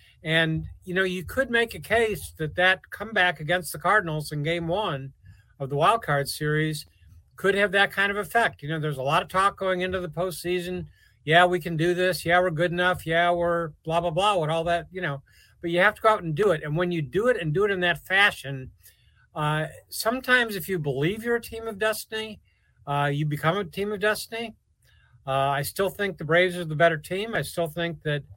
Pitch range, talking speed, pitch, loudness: 150-195 Hz, 230 wpm, 175 Hz, -25 LUFS